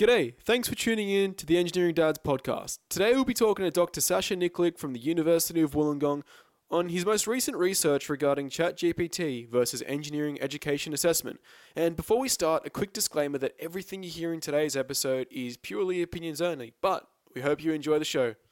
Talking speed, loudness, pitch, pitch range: 195 wpm, -28 LUFS, 165 Hz, 145-180 Hz